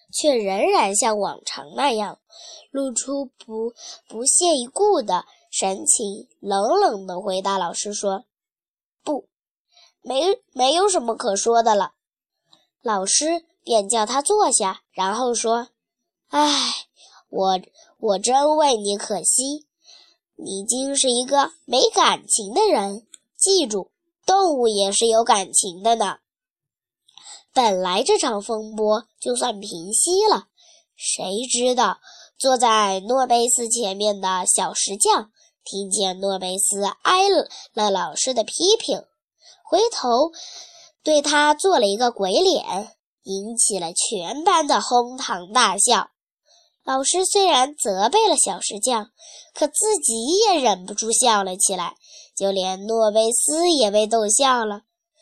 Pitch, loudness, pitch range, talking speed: 240 Hz, -20 LUFS, 205-320 Hz, 175 characters per minute